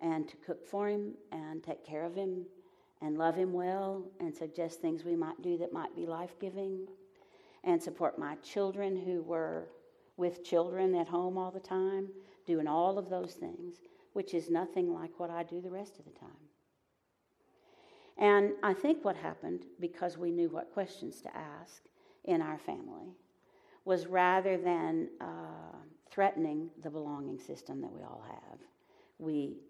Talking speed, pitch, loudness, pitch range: 165 wpm, 185 Hz, -36 LUFS, 170-195 Hz